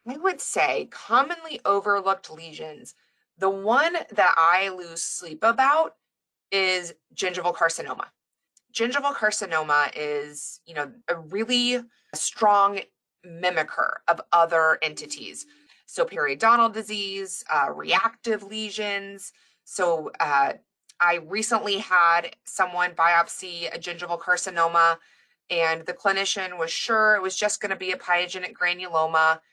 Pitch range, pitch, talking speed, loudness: 170-220 Hz, 190 Hz, 120 wpm, -24 LUFS